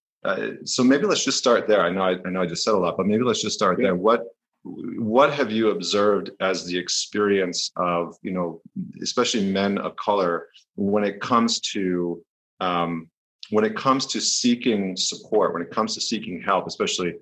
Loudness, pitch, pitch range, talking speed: -22 LUFS, 95 Hz, 90-110 Hz, 195 wpm